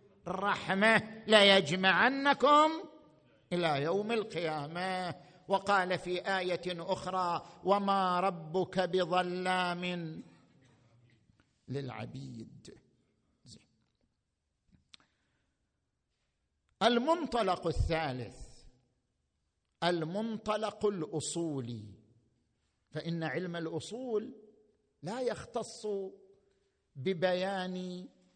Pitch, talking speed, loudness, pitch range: 180 Hz, 50 wpm, -32 LUFS, 155-200 Hz